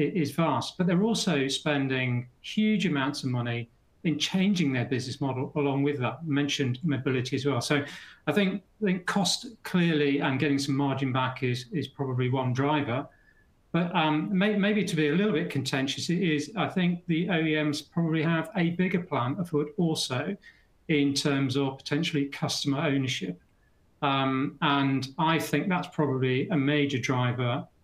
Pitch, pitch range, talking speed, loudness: 145 Hz, 135-165 Hz, 170 wpm, -28 LUFS